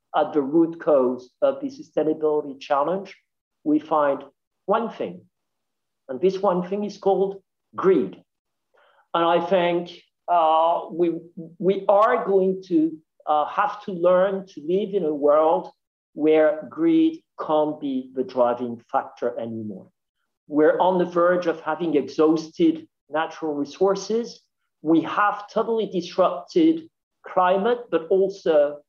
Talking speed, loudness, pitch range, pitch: 125 wpm, -22 LUFS, 155-195 Hz, 175 Hz